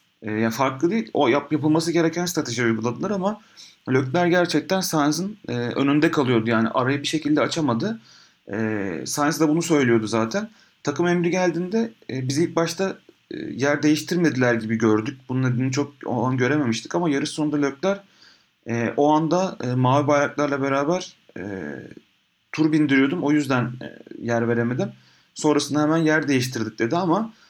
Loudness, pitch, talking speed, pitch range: -22 LUFS, 145 Hz, 155 wpm, 120-170 Hz